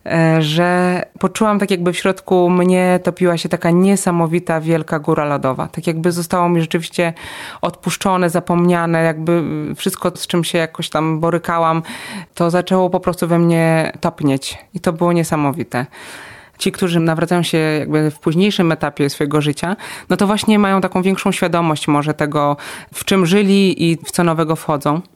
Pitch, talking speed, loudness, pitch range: 170 Hz, 160 wpm, -16 LUFS, 160-180 Hz